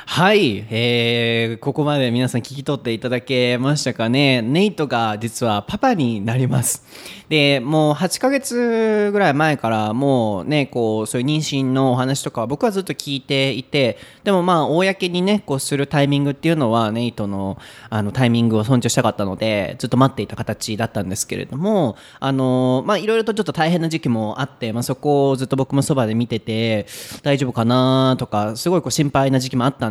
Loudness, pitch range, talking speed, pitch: -19 LUFS, 115-150 Hz, 375 characters per minute, 130 Hz